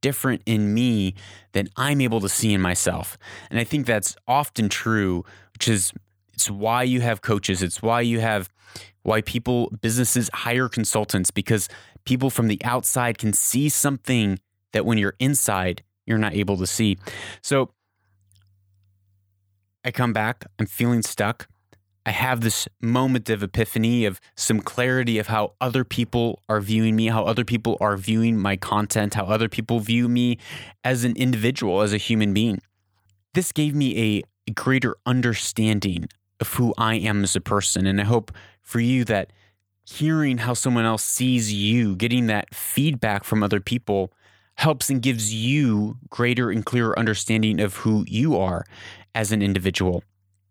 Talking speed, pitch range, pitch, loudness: 165 wpm, 100-120 Hz, 110 Hz, -22 LUFS